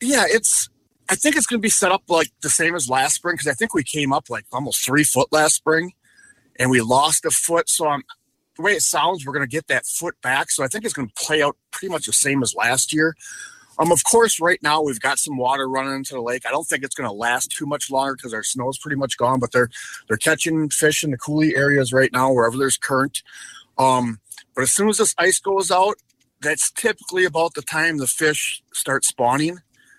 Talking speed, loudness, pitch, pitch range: 245 wpm, -19 LUFS, 150 Hz, 135-170 Hz